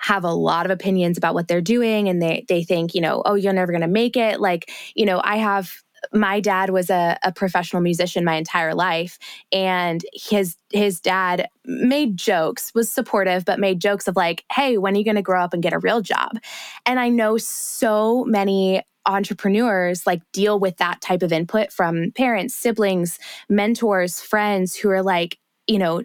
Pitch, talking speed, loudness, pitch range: 195 Hz, 200 wpm, -20 LUFS, 180-215 Hz